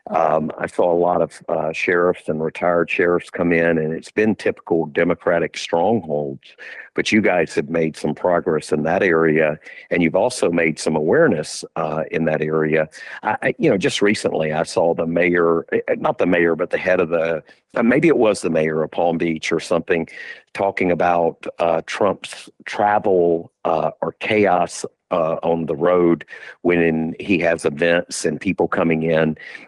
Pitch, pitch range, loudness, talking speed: 85 Hz, 80-85 Hz, -19 LUFS, 175 wpm